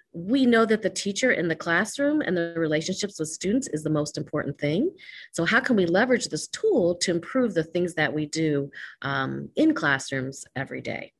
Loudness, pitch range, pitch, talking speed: -25 LUFS, 150-230 Hz, 175 Hz, 200 wpm